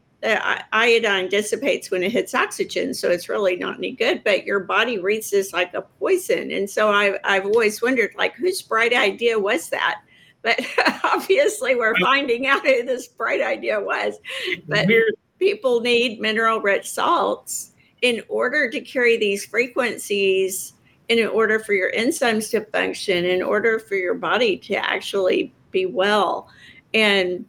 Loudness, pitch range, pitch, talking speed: -20 LUFS, 200-320 Hz, 225 Hz, 155 wpm